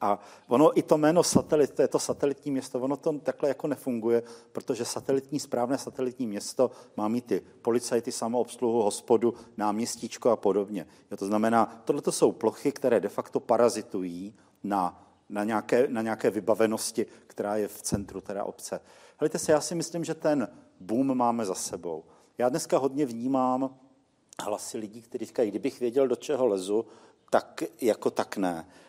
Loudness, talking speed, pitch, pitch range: -28 LUFS, 165 wpm, 120 Hz, 110-135 Hz